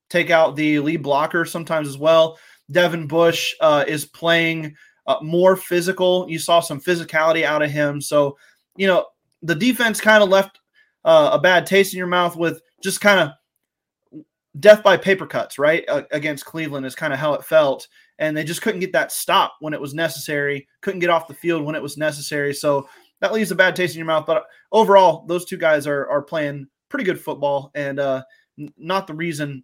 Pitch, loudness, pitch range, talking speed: 165 Hz, -19 LUFS, 150-185 Hz, 205 wpm